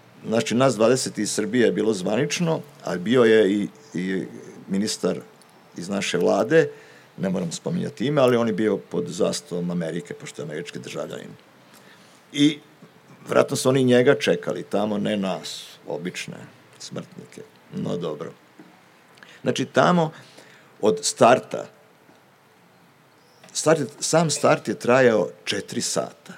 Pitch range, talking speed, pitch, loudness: 110-155 Hz, 125 wpm, 130 Hz, -22 LUFS